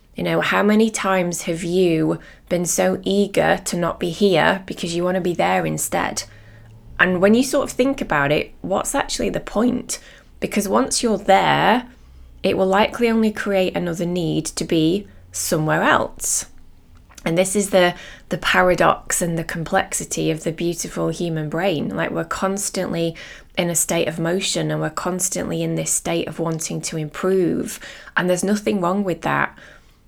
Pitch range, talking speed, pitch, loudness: 155-195 Hz, 170 wpm, 175 Hz, -20 LUFS